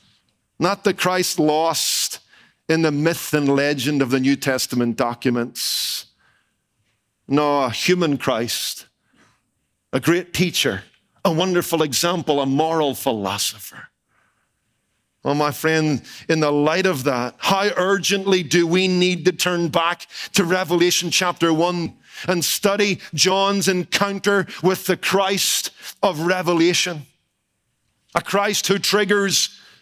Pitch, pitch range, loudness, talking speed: 170 Hz, 140-185 Hz, -19 LUFS, 120 wpm